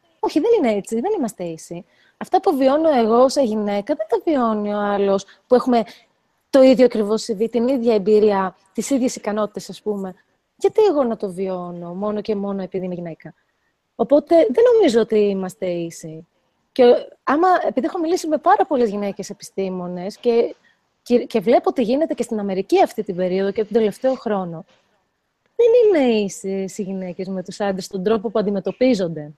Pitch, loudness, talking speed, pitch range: 220 Hz, -19 LUFS, 180 wpm, 195-265 Hz